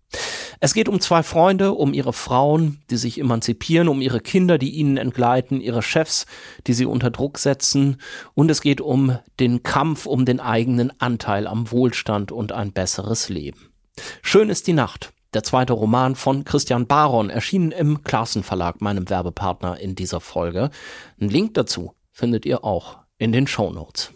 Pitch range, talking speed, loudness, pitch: 110-145 Hz, 165 wpm, -20 LUFS, 125 Hz